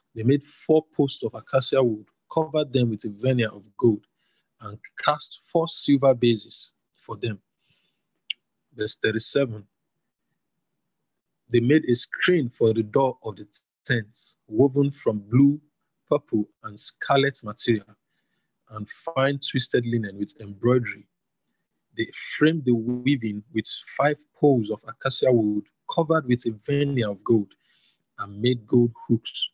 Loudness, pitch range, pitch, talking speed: -24 LUFS, 110-140 Hz, 125 Hz, 135 wpm